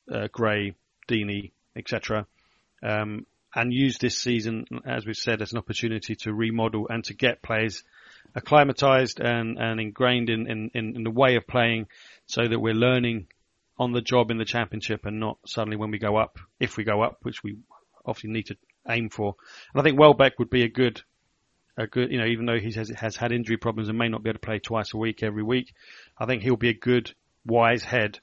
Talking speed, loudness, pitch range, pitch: 215 wpm, -25 LUFS, 110-120 Hz, 115 Hz